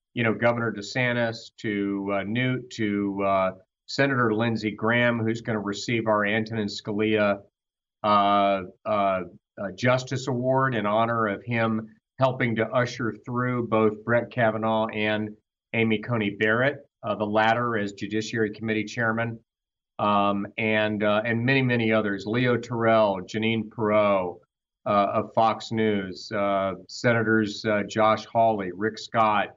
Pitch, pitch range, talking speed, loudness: 110 Hz, 105-115 Hz, 140 wpm, -25 LUFS